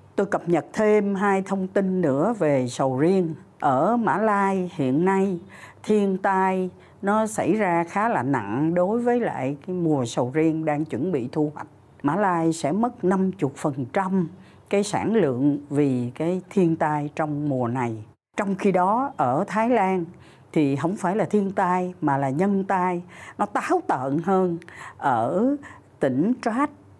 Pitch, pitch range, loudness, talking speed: 180 Hz, 150-200 Hz, -23 LUFS, 165 wpm